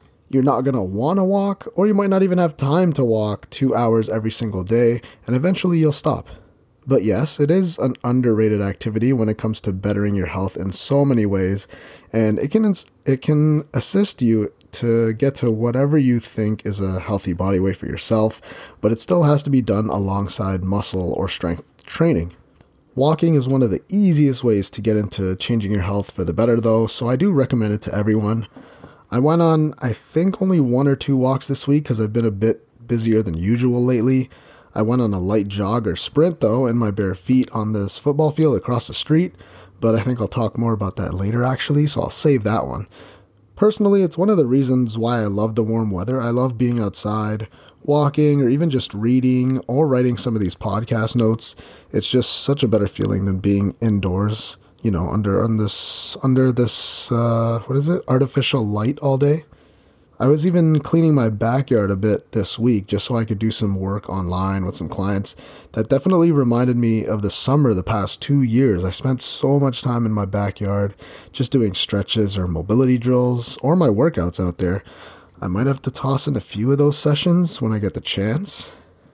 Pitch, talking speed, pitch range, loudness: 115 Hz, 210 wpm, 105-135 Hz, -19 LUFS